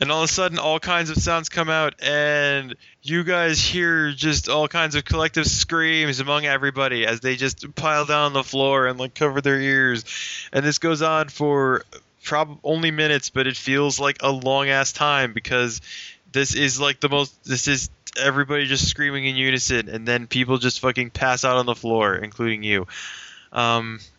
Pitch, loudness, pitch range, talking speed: 140 Hz, -21 LUFS, 130-150 Hz, 195 wpm